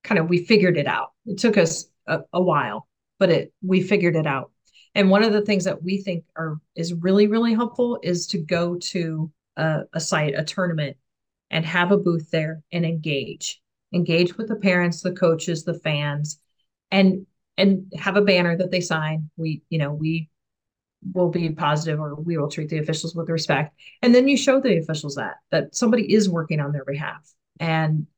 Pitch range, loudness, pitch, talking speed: 155-190 Hz, -22 LUFS, 170 Hz, 200 wpm